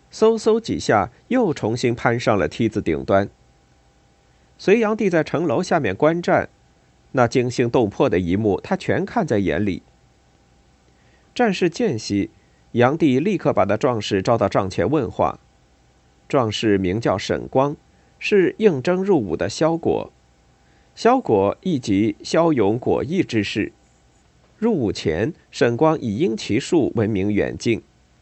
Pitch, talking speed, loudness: 105 Hz, 200 characters per minute, -20 LUFS